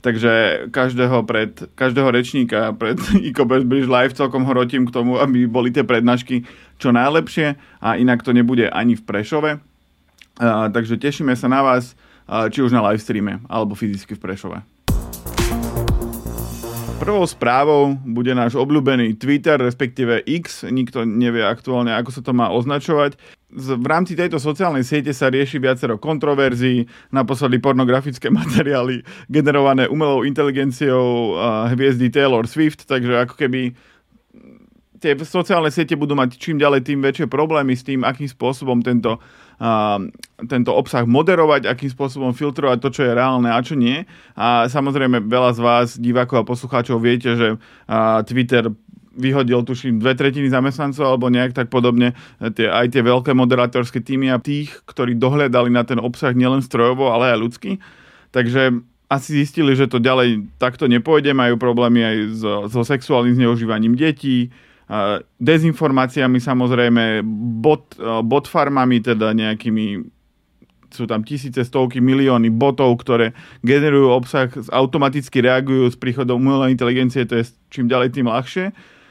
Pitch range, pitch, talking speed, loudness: 120-140 Hz, 125 Hz, 145 wpm, -17 LUFS